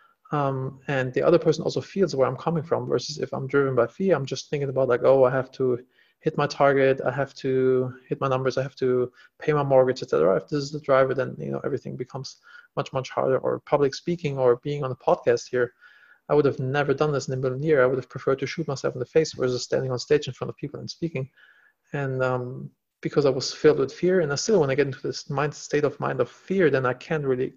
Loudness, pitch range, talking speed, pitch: -24 LUFS, 130-150 Hz, 260 wpm, 135 Hz